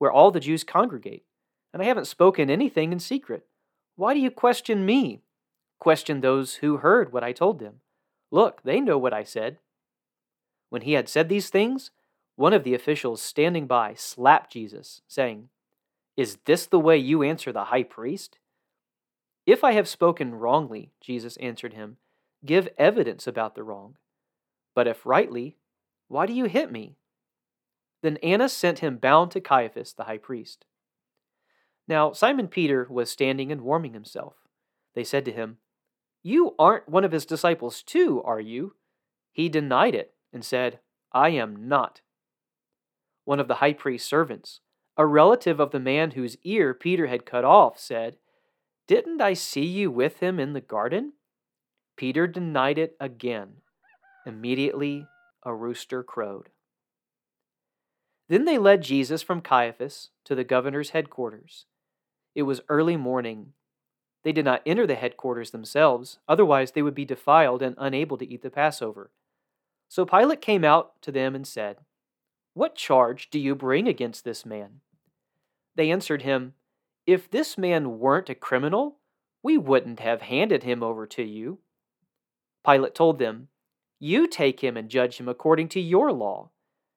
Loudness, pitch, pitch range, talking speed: -24 LUFS, 145 Hz, 125-175 Hz, 155 wpm